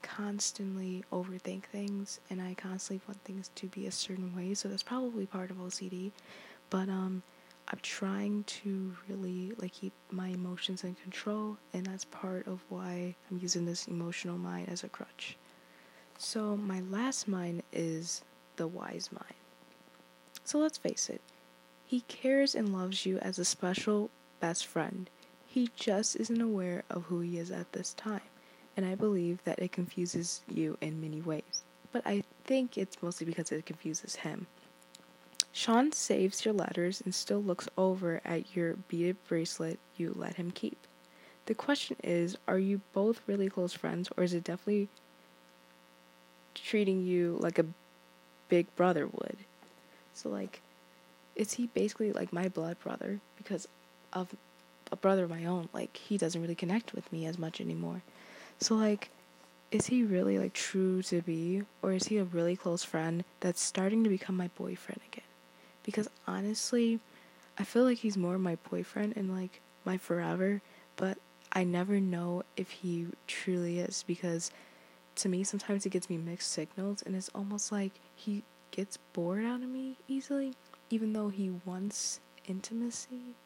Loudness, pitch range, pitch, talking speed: -35 LUFS, 165-200 Hz, 185 Hz, 165 wpm